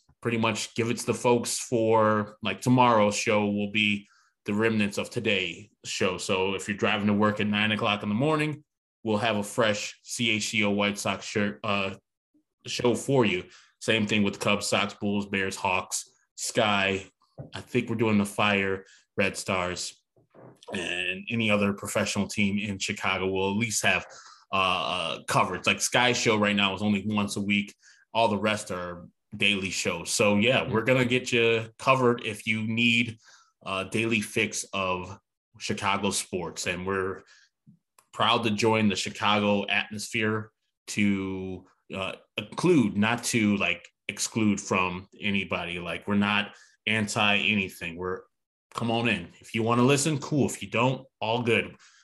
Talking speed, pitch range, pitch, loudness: 165 wpm, 100-115 Hz, 105 Hz, -26 LUFS